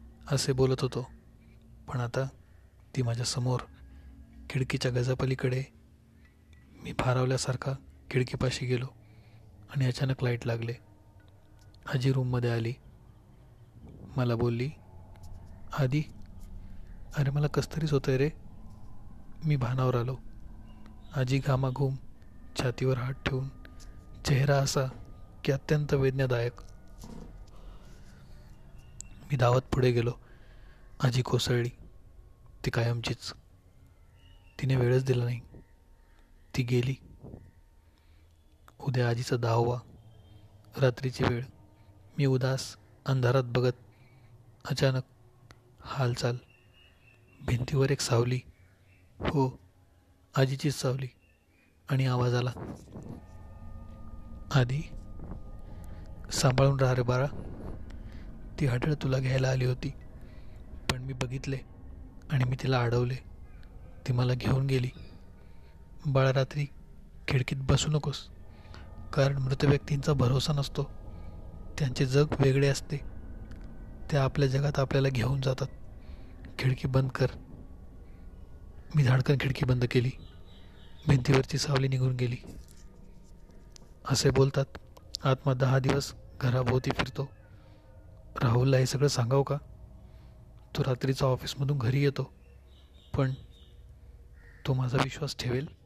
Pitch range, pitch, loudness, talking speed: 95-135 Hz, 120 Hz, -30 LUFS, 95 wpm